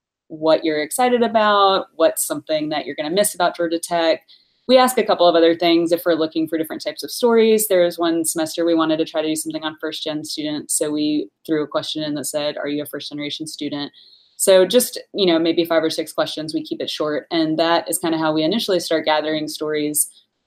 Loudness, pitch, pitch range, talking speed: -19 LUFS, 165 Hz, 155-210 Hz, 240 wpm